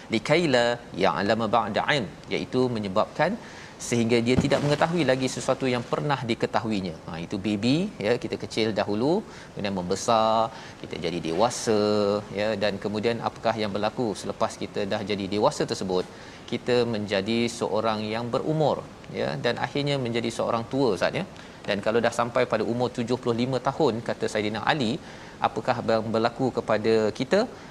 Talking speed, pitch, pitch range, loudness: 145 wpm, 115 Hz, 105-125 Hz, -26 LUFS